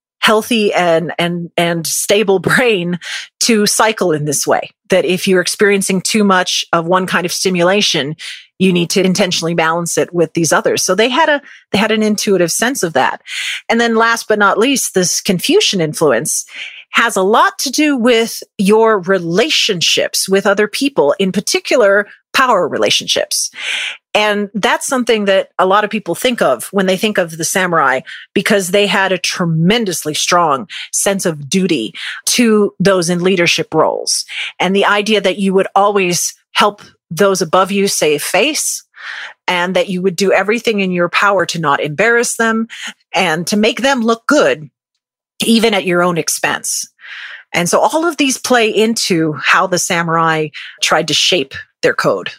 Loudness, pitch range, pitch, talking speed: -13 LUFS, 175-220 Hz, 195 Hz, 170 wpm